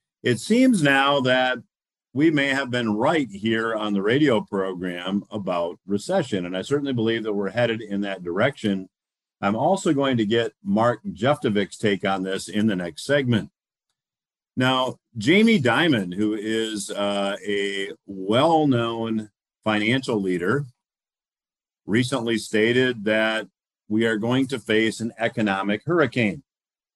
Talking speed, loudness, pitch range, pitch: 135 wpm, -23 LUFS, 100-130 Hz, 110 Hz